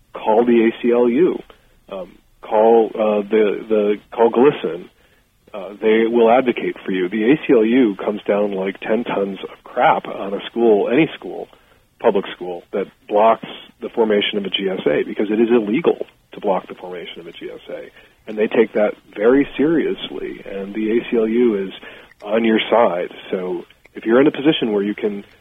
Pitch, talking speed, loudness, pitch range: 110 Hz, 170 wpm, -18 LUFS, 105-120 Hz